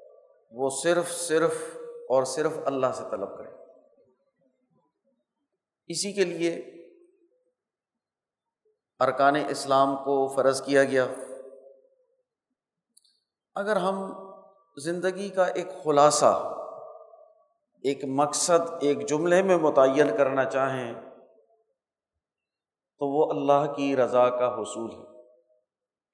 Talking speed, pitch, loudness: 90 wpm, 170 Hz, -25 LUFS